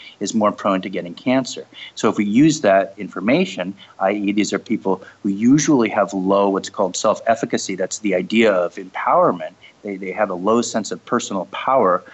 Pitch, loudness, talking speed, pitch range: 100 Hz, -19 LUFS, 190 wpm, 95-110 Hz